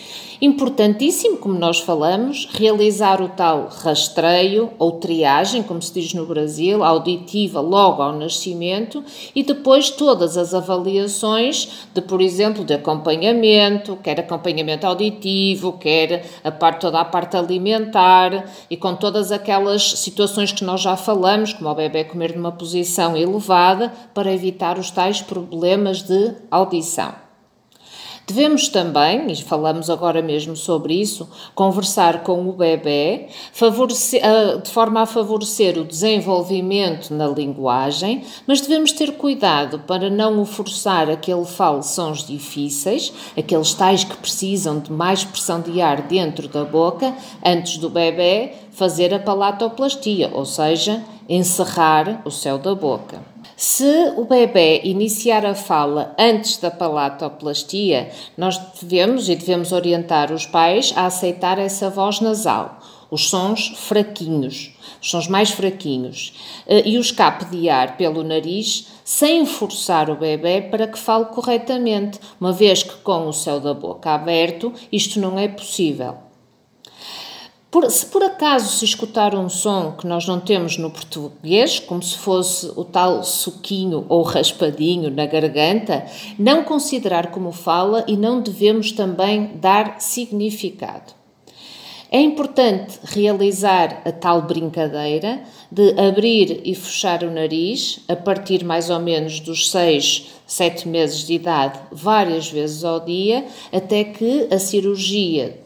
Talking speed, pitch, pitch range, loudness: 135 wpm, 185 Hz, 165-210 Hz, -18 LUFS